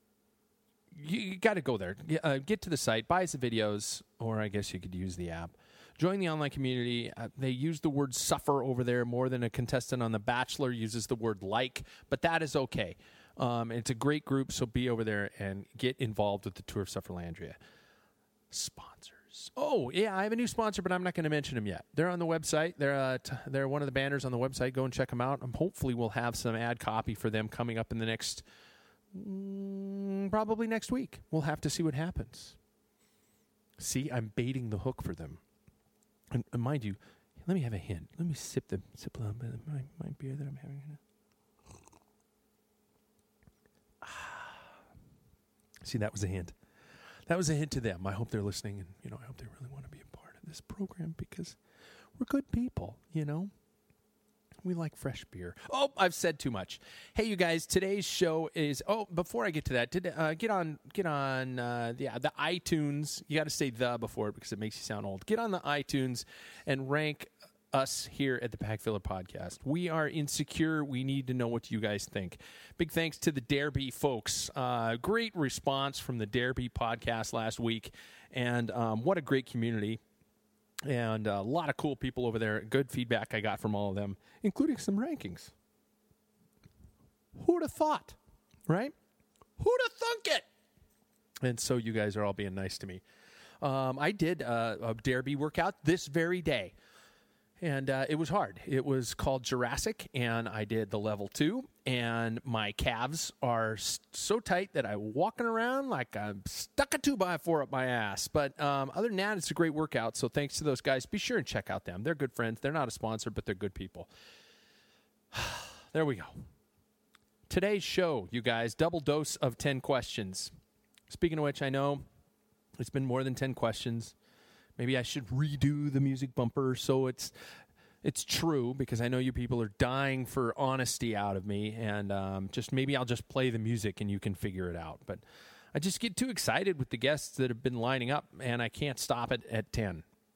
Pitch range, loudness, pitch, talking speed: 115-160 Hz, -34 LUFS, 130 Hz, 205 wpm